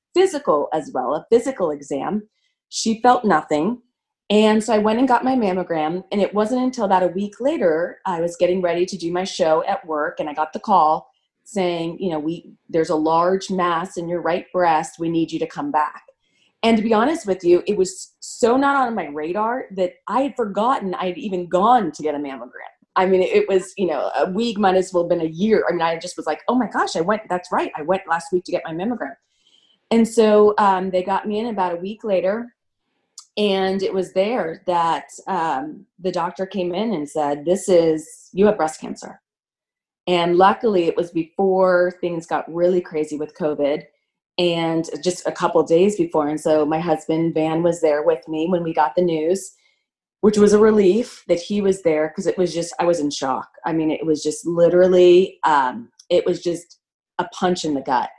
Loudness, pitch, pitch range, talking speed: -20 LUFS, 180 Hz, 165-210 Hz, 215 wpm